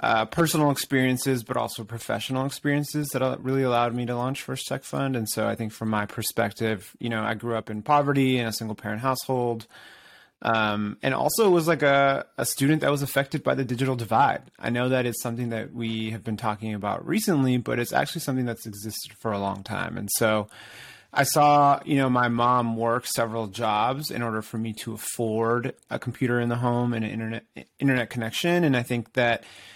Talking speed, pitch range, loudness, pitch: 210 wpm, 110-130 Hz, -25 LUFS, 120 Hz